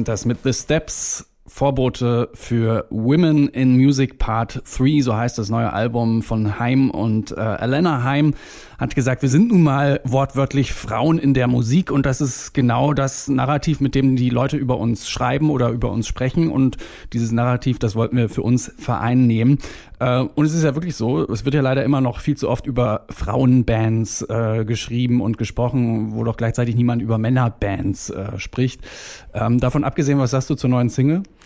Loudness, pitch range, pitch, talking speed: -19 LUFS, 115-135 Hz, 125 Hz, 185 wpm